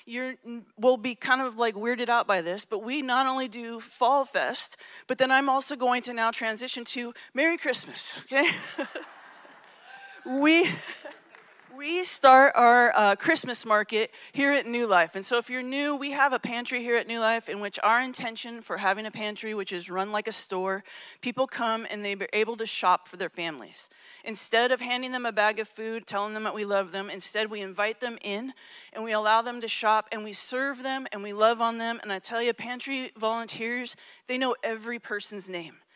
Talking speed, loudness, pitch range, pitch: 205 wpm, -26 LUFS, 215-255 Hz, 230 Hz